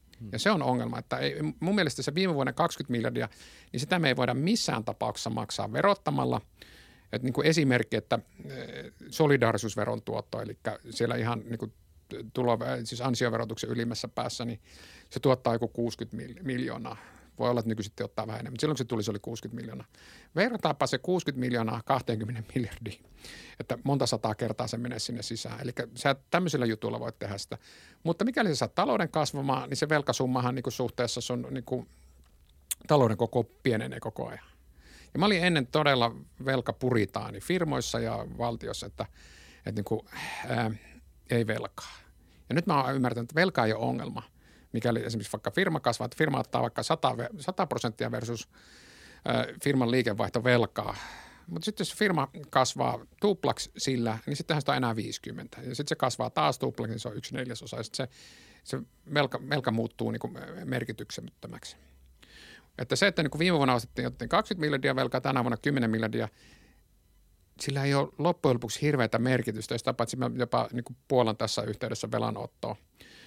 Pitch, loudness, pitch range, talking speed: 120 Hz, -30 LUFS, 110-135 Hz, 165 wpm